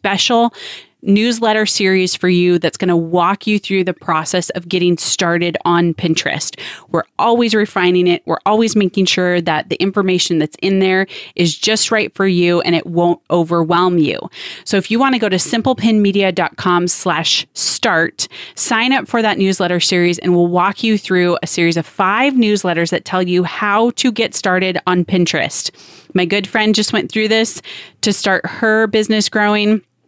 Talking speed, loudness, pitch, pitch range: 175 wpm, -15 LUFS, 185 Hz, 175-215 Hz